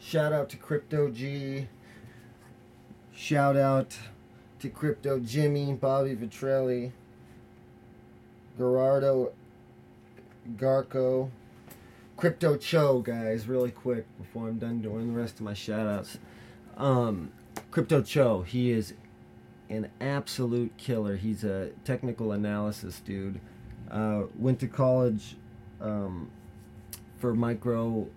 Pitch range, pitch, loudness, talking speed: 110-135 Hz, 120 Hz, -29 LUFS, 105 wpm